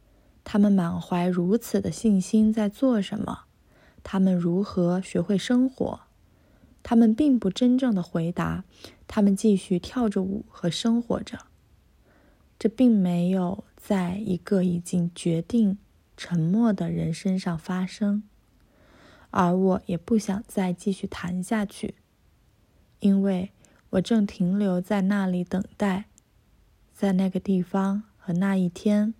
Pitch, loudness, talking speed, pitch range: 195 Hz, -25 LUFS, 185 characters per minute, 180-210 Hz